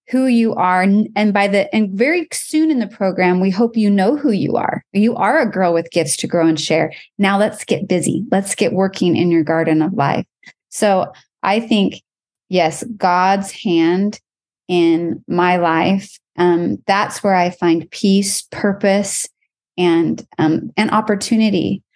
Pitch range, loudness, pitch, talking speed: 175-210 Hz, -16 LUFS, 195 Hz, 165 wpm